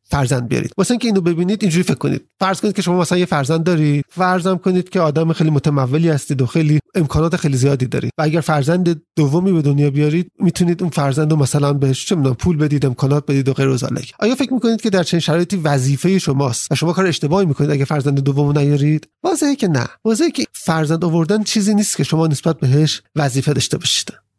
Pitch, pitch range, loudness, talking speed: 160 Hz, 145-185 Hz, -16 LUFS, 205 wpm